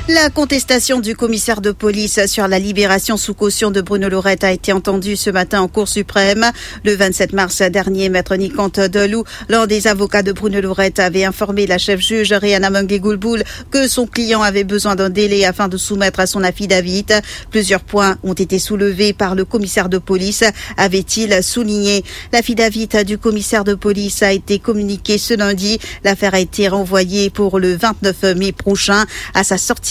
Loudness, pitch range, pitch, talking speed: -14 LUFS, 195-215 Hz, 200 Hz, 175 wpm